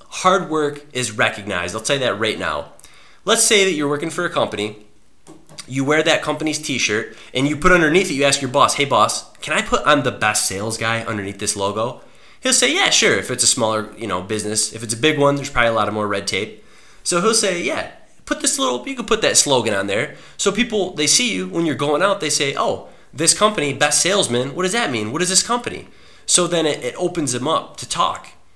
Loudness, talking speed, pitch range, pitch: -17 LUFS, 245 wpm, 115-185 Hz, 145 Hz